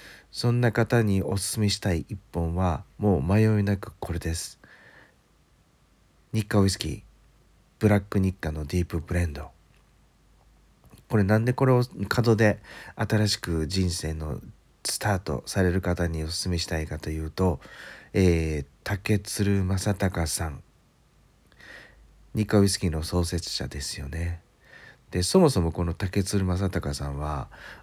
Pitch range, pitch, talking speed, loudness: 80-105 Hz, 90 Hz, 260 characters per minute, -26 LUFS